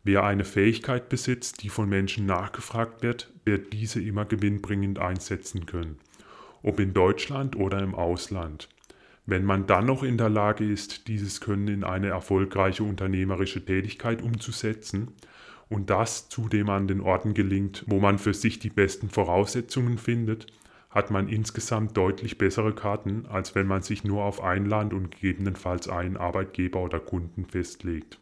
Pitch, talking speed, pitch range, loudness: 100 Hz, 155 wpm, 95-110 Hz, -27 LUFS